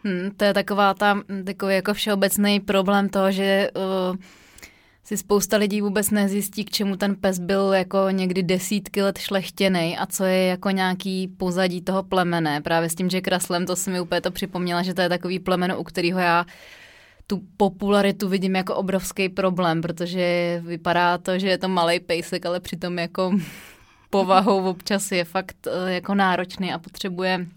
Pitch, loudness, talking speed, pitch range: 190 Hz, -22 LUFS, 175 wpm, 180-195 Hz